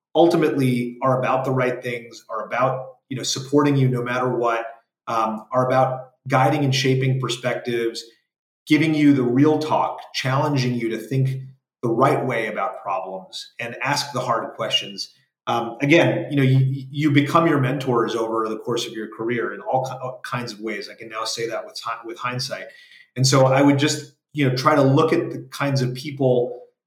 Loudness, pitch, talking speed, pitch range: -21 LUFS, 130 Hz, 190 wpm, 120-140 Hz